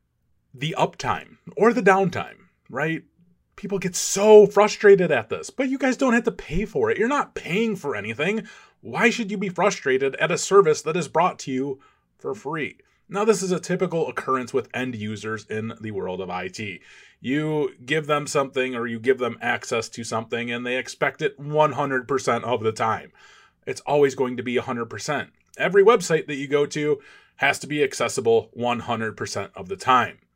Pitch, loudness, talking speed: 150 Hz, -23 LUFS, 185 wpm